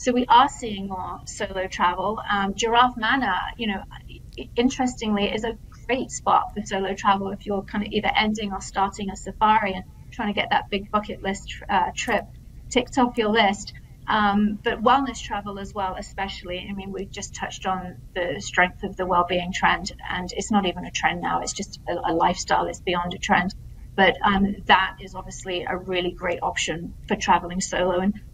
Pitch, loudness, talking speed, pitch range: 200 Hz, -24 LUFS, 195 wpm, 185-215 Hz